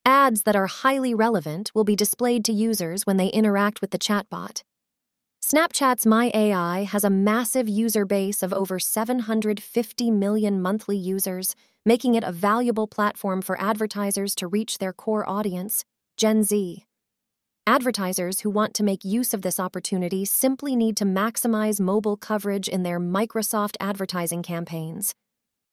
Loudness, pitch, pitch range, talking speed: -23 LUFS, 210 Hz, 195-225 Hz, 150 wpm